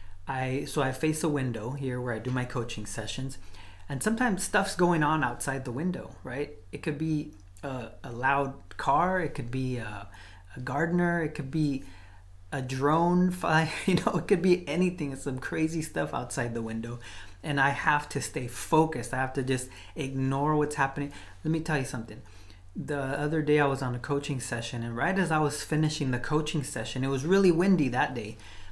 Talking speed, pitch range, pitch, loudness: 200 wpm, 120-155 Hz, 135 Hz, -29 LUFS